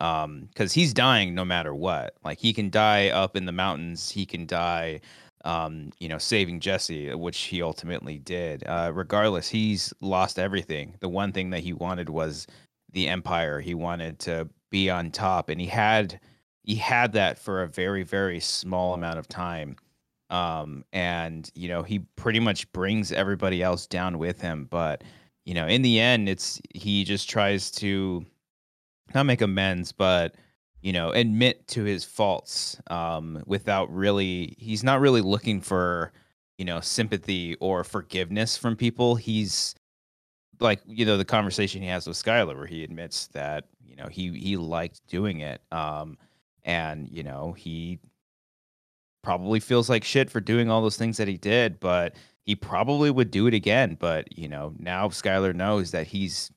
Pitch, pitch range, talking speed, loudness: 95 Hz, 85-105 Hz, 175 wpm, -26 LUFS